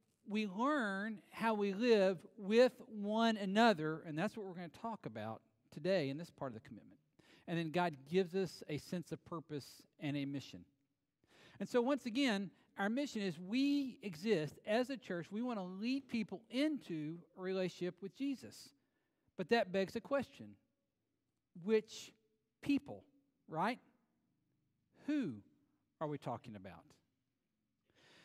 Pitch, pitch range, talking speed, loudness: 195 Hz, 160-230 Hz, 150 wpm, -39 LUFS